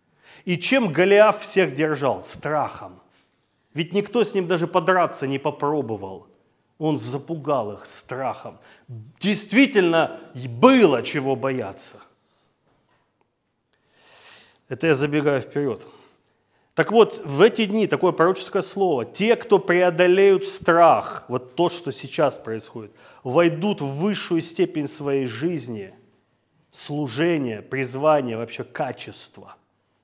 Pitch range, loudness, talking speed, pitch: 135-190 Hz, -21 LUFS, 105 wpm, 165 Hz